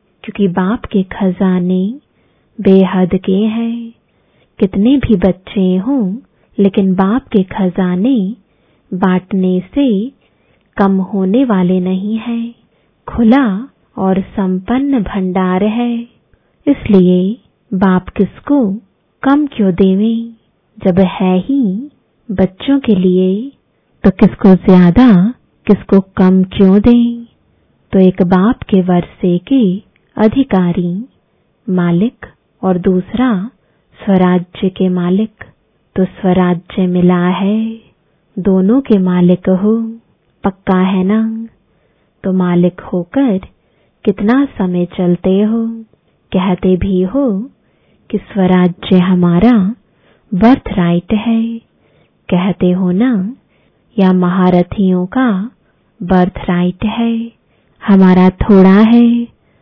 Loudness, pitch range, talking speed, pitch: -12 LUFS, 185-230 Hz, 100 wpm, 195 Hz